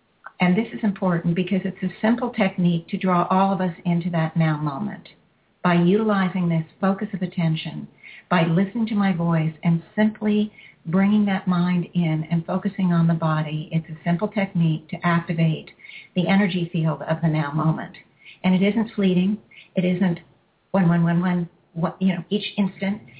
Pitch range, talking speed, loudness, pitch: 170-195 Hz, 175 wpm, -22 LUFS, 180 Hz